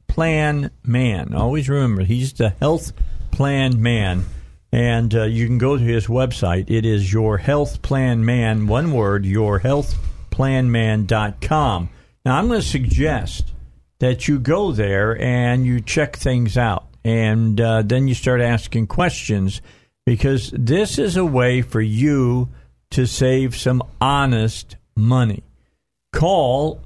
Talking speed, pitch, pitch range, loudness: 140 wpm, 120 Hz, 110-130 Hz, -19 LUFS